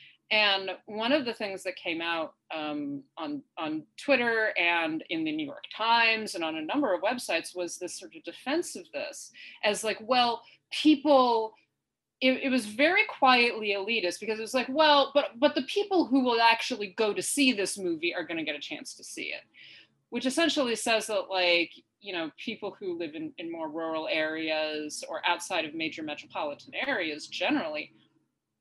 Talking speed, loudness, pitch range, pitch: 185 wpm, -28 LUFS, 170-265 Hz, 215 Hz